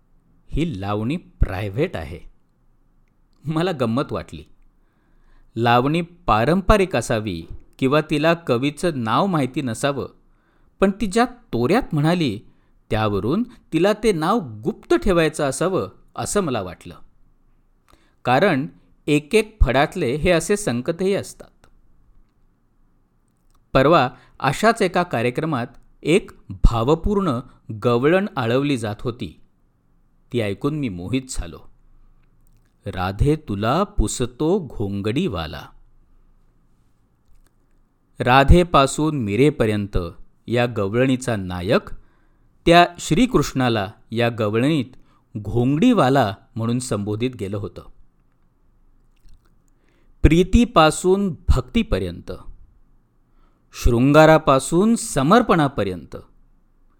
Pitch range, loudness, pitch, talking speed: 110-165 Hz, -20 LUFS, 130 Hz, 80 wpm